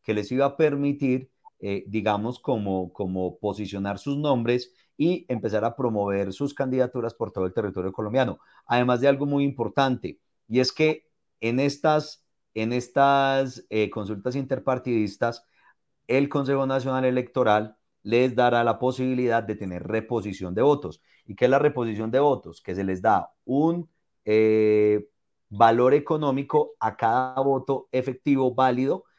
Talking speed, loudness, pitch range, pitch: 145 wpm, -24 LUFS, 110-135 Hz, 125 Hz